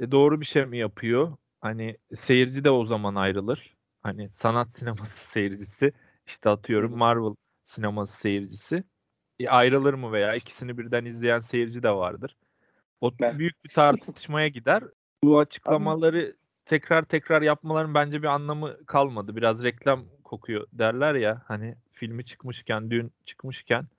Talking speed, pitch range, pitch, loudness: 140 wpm, 110-145 Hz, 120 Hz, -25 LUFS